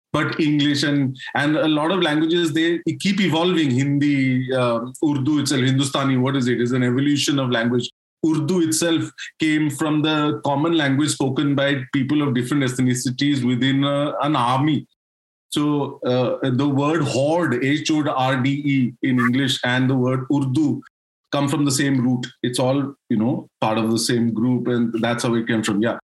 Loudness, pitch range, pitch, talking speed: -20 LUFS, 125-150 Hz, 140 Hz, 180 wpm